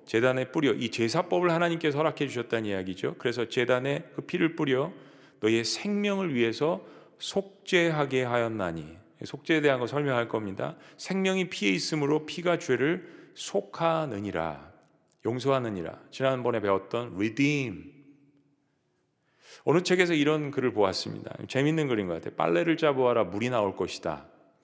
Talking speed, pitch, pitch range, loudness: 340 characters per minute, 140 Hz, 115-160 Hz, -28 LUFS